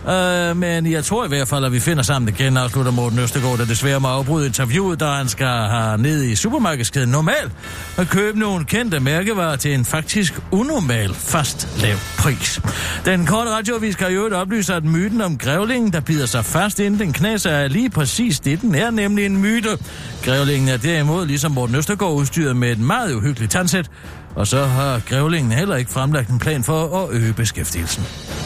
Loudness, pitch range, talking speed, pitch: -18 LUFS, 125-185 Hz, 195 wpm, 145 Hz